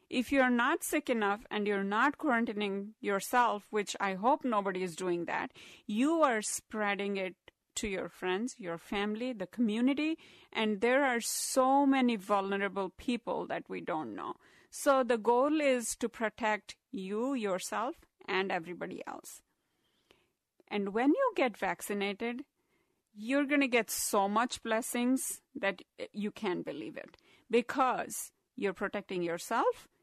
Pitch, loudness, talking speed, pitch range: 225 Hz, -32 LUFS, 140 wpm, 200-260 Hz